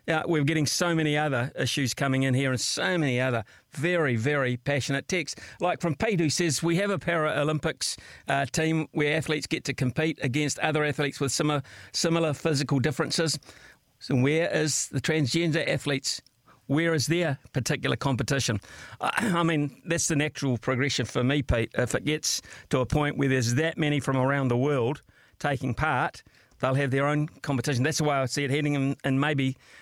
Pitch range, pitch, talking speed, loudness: 135-155 Hz, 145 Hz, 185 wpm, -27 LUFS